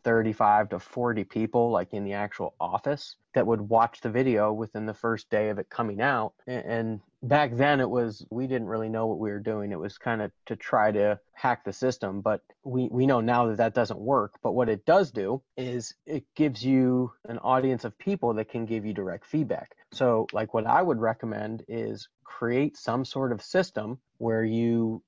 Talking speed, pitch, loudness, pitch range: 210 wpm, 115 Hz, -28 LUFS, 110-130 Hz